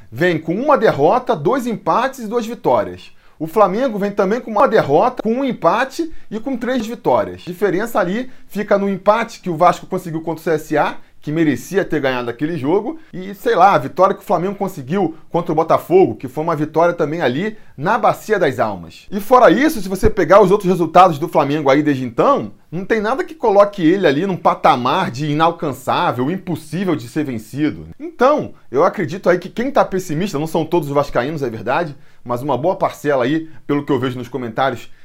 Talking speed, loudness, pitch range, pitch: 205 wpm, -17 LUFS, 150-210 Hz, 175 Hz